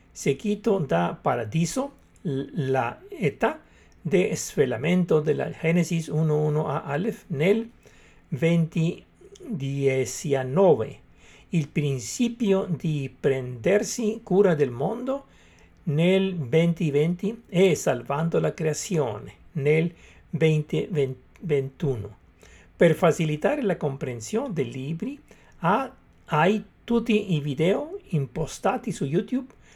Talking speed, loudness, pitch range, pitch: 90 wpm, -25 LUFS, 145-195 Hz, 165 Hz